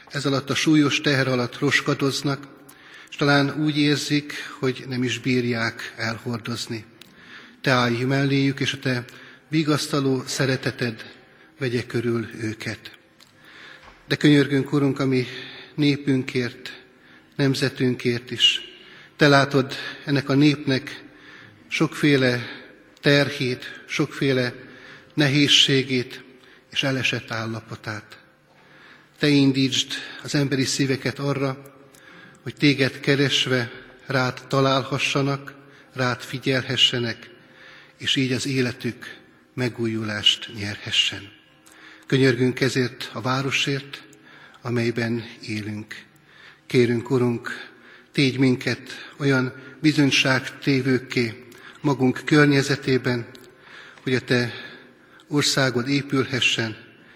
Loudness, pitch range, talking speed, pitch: -22 LUFS, 125-140 Hz, 90 wpm, 130 Hz